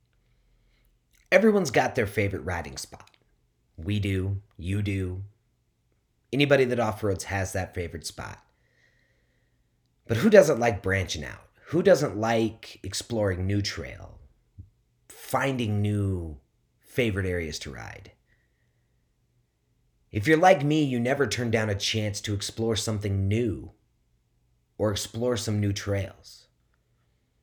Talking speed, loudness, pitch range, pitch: 120 wpm, -26 LUFS, 95-120 Hz, 105 Hz